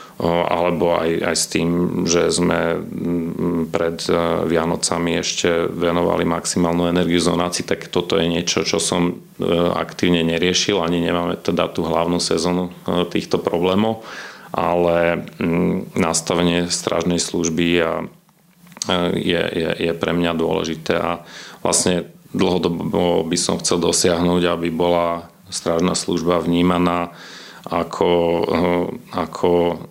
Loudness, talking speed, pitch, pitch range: -19 LUFS, 110 wpm, 85 Hz, 85-90 Hz